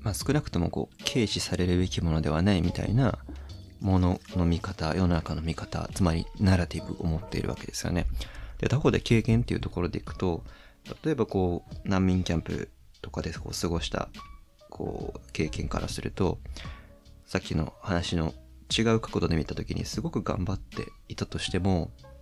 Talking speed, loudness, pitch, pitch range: 355 characters per minute, -29 LUFS, 90 Hz, 80-100 Hz